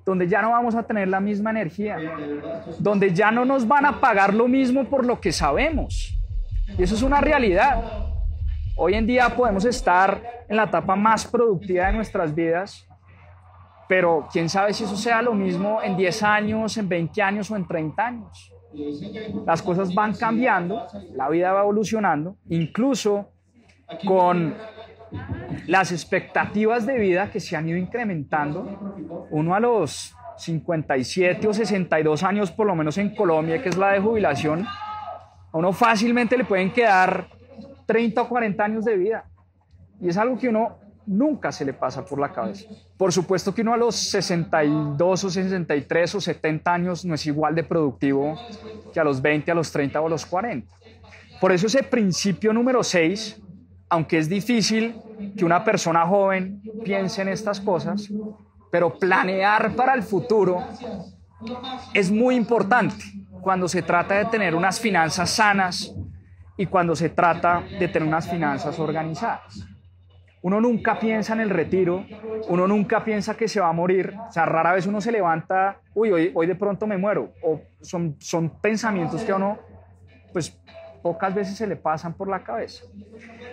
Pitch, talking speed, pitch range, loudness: 190 Hz, 165 wpm, 160-220 Hz, -22 LUFS